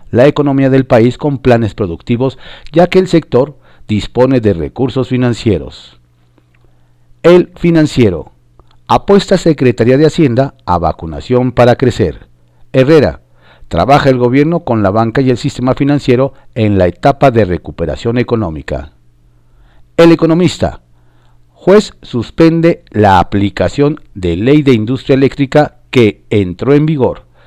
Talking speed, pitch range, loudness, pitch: 125 wpm, 85-140 Hz, -11 LUFS, 120 Hz